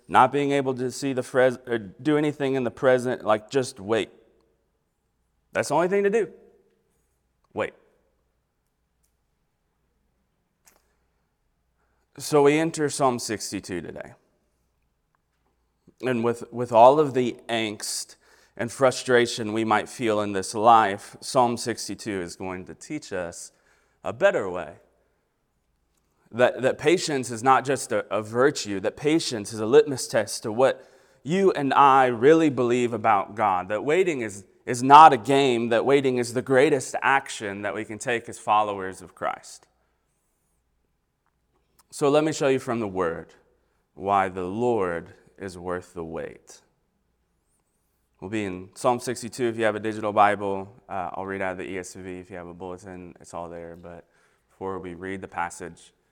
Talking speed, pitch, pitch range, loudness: 155 wpm, 115 Hz, 95-130 Hz, -23 LUFS